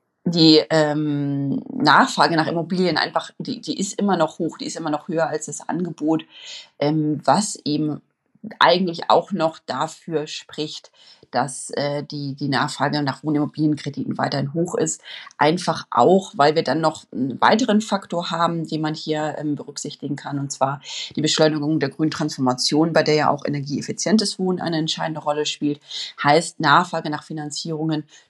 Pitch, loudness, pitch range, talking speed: 155 Hz, -21 LUFS, 145-170 Hz, 155 wpm